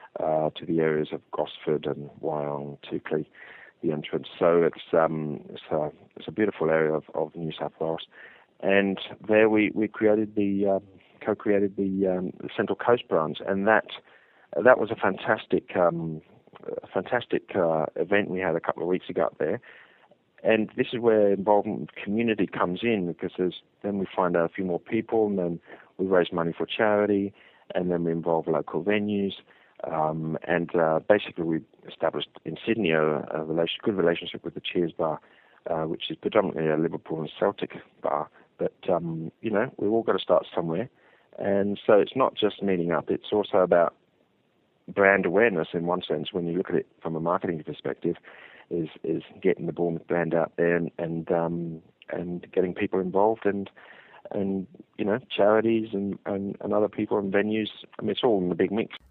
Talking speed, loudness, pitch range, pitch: 185 wpm, -26 LUFS, 80-100 Hz, 90 Hz